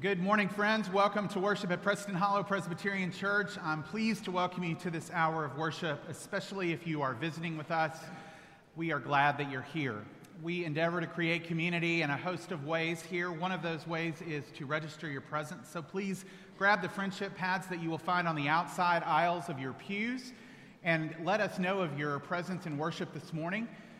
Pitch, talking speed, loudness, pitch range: 170 Hz, 205 wpm, -34 LUFS, 160-195 Hz